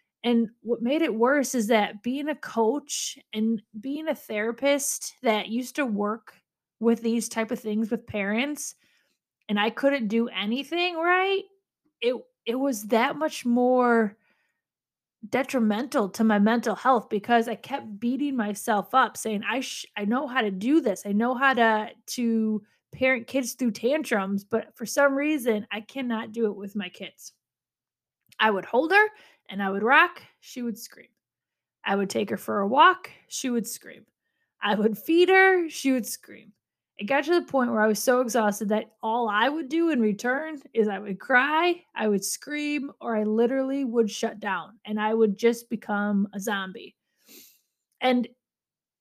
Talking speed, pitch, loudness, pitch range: 175 wpm, 235 Hz, -25 LUFS, 215-275 Hz